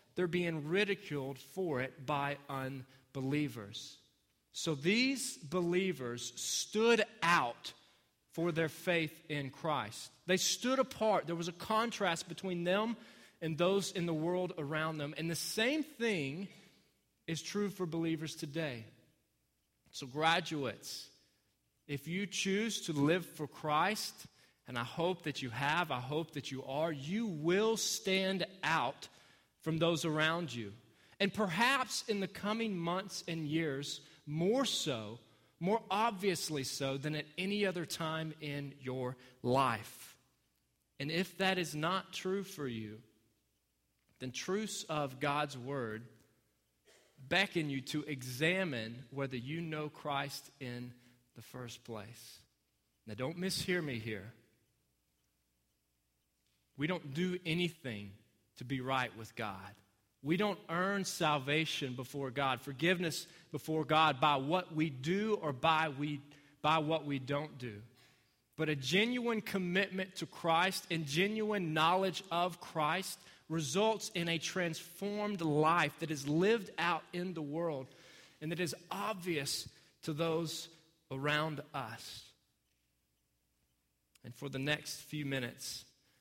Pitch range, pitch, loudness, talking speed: 130-180 Hz, 155 Hz, -36 LUFS, 130 wpm